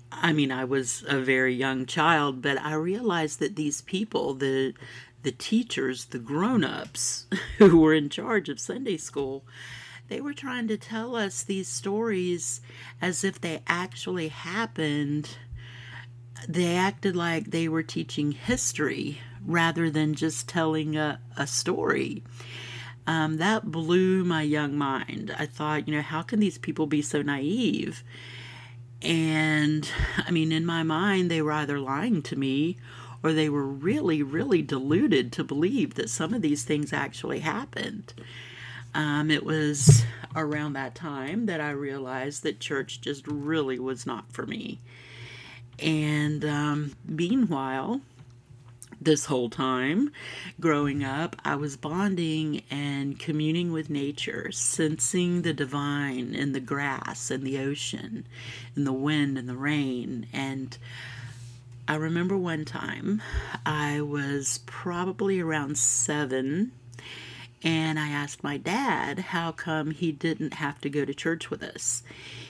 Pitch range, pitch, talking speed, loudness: 130-160 Hz, 145 Hz, 140 wpm, -27 LUFS